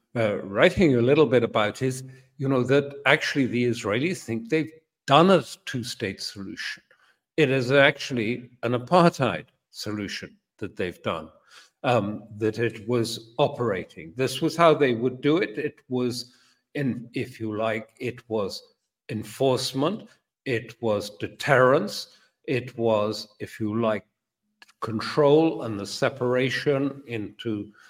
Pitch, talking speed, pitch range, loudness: 125 Hz, 135 wpm, 110-140 Hz, -25 LUFS